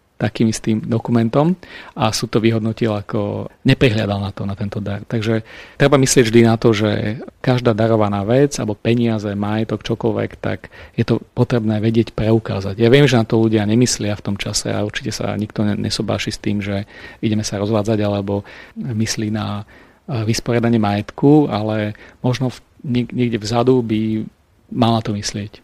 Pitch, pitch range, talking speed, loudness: 110 Hz, 105-120 Hz, 165 wpm, -18 LUFS